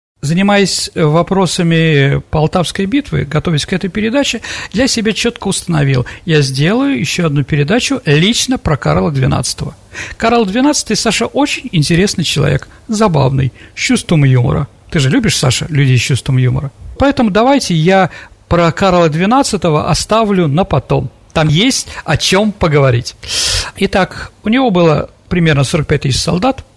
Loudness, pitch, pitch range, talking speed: -12 LUFS, 170 Hz, 145-215 Hz, 135 wpm